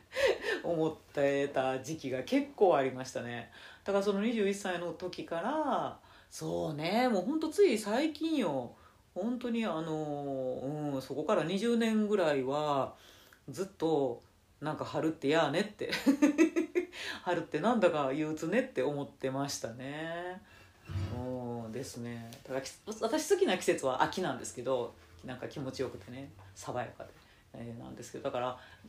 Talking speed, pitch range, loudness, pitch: 285 characters per minute, 130-210 Hz, -33 LUFS, 155 Hz